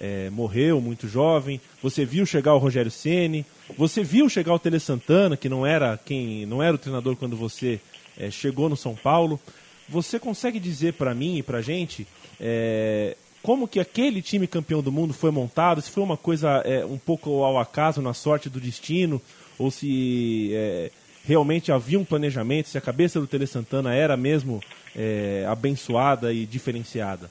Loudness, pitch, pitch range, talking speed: -24 LUFS, 140 Hz, 125-165 Hz, 180 wpm